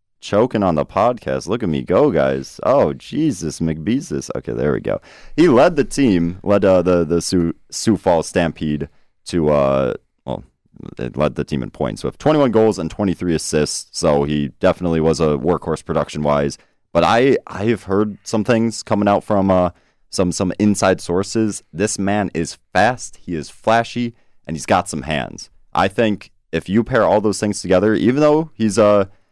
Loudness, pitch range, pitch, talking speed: -18 LUFS, 80-105 Hz, 95 Hz, 185 wpm